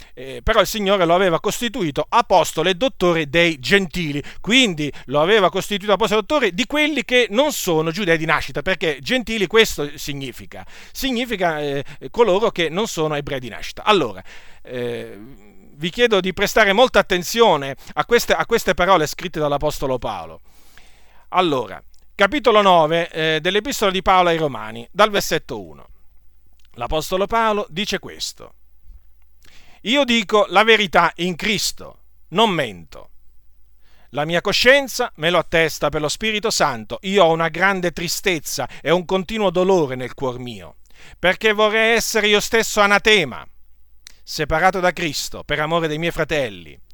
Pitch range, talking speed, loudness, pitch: 145-210 Hz, 145 wpm, -18 LUFS, 175 Hz